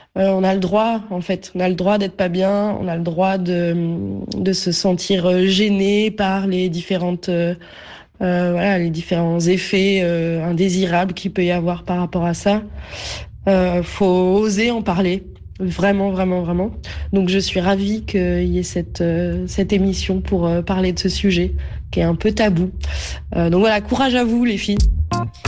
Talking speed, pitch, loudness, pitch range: 185 wpm, 185 Hz, -18 LUFS, 175-195 Hz